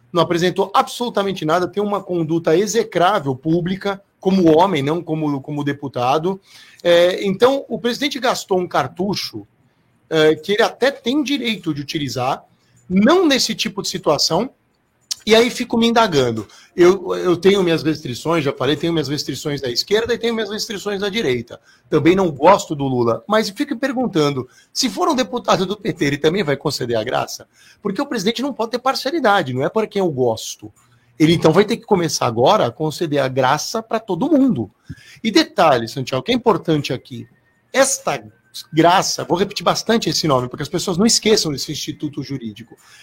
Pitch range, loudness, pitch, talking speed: 150-220 Hz, -18 LUFS, 175 Hz, 175 wpm